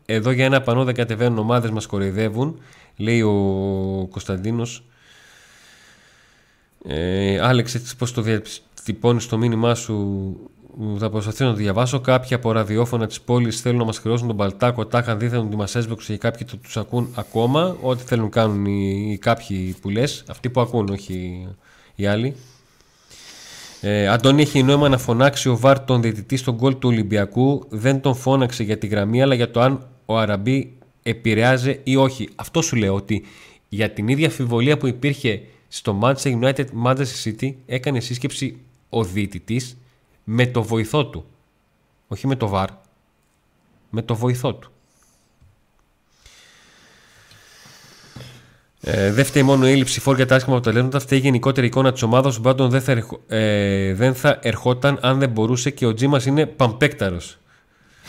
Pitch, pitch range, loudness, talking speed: 120 Hz, 110-130 Hz, -20 LUFS, 155 wpm